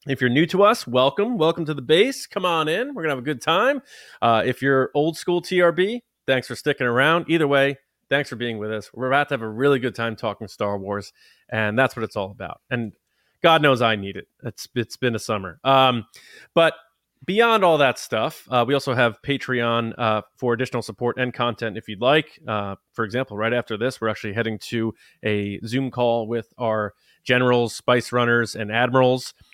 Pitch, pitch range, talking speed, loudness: 125 Hz, 115-140 Hz, 210 wpm, -22 LUFS